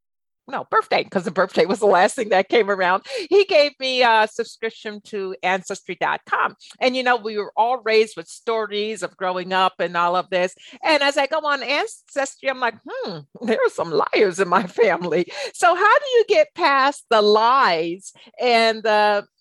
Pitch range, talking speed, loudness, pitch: 195-285 Hz, 190 wpm, -19 LUFS, 225 Hz